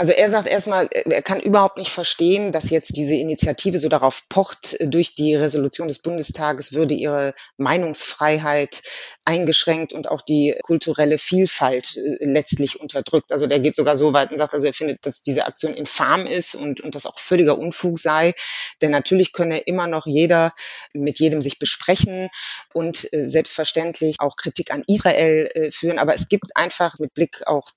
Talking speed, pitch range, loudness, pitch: 170 wpm, 150-170 Hz, -19 LUFS, 155 Hz